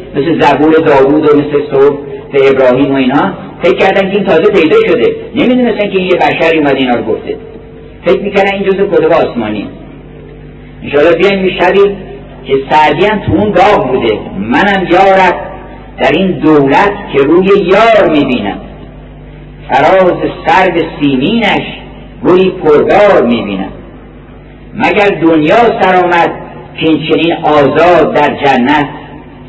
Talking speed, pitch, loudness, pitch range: 130 wpm, 180 Hz, -8 LUFS, 150-200 Hz